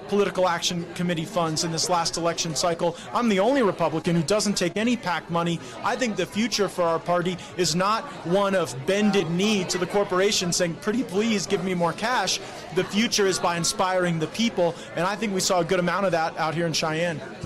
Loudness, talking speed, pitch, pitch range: -24 LUFS, 215 wpm, 180 Hz, 170-200 Hz